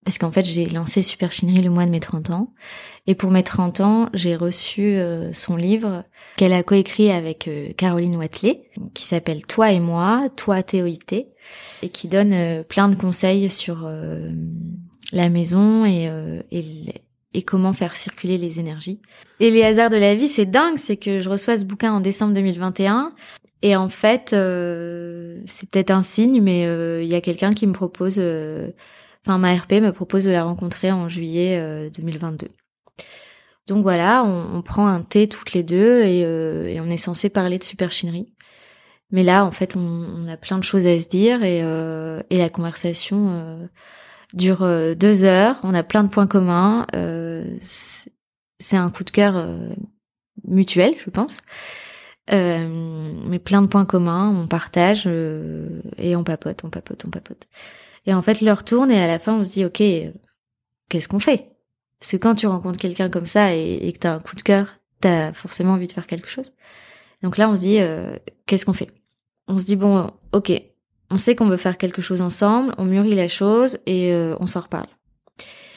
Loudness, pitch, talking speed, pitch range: -19 LUFS, 185 Hz, 195 wpm, 170-205 Hz